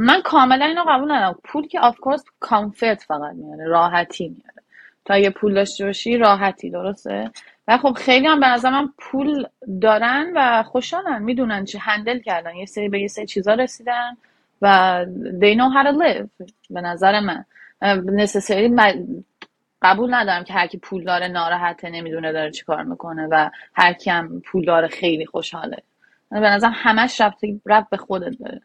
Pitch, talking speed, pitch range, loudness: 210 Hz, 165 wpm, 185-250 Hz, -18 LUFS